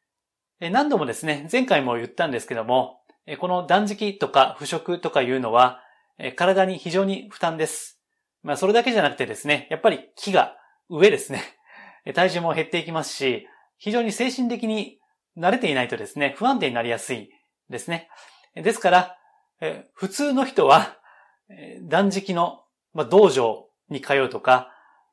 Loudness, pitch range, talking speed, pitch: -22 LUFS, 145-215 Hz, 295 characters per minute, 175 Hz